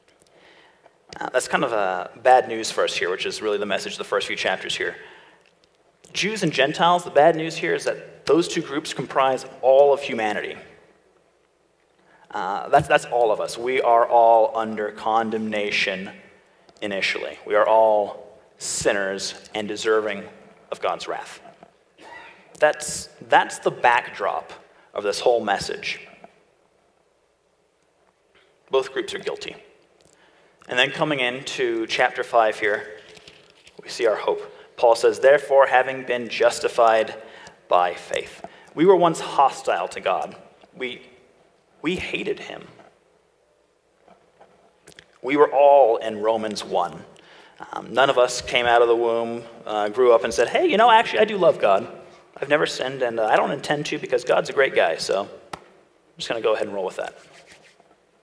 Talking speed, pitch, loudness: 160 wpm, 140 Hz, -21 LUFS